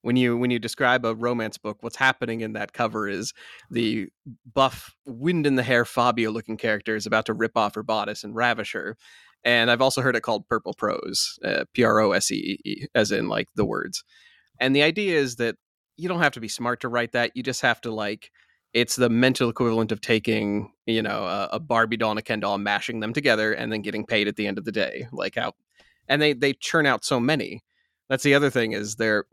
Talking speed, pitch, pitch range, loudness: 235 wpm, 115 Hz, 110-130 Hz, -24 LUFS